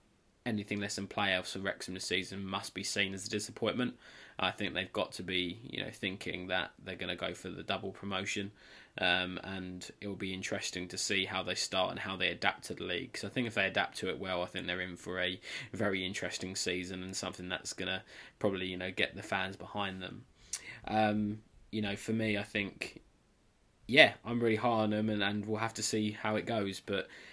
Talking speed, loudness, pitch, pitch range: 230 wpm, -35 LUFS, 95 Hz, 90-105 Hz